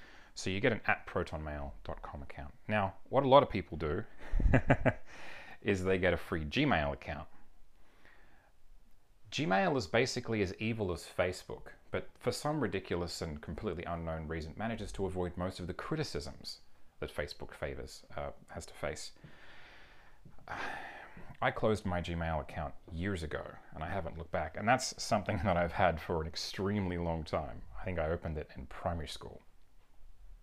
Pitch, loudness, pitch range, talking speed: 90 Hz, -35 LUFS, 80-100 Hz, 160 wpm